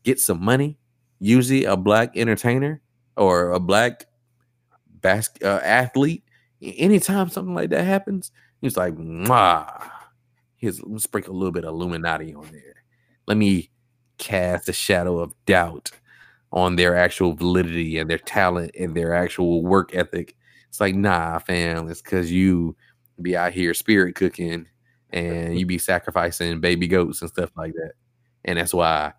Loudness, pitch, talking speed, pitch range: -21 LUFS, 95 Hz, 155 wpm, 85-120 Hz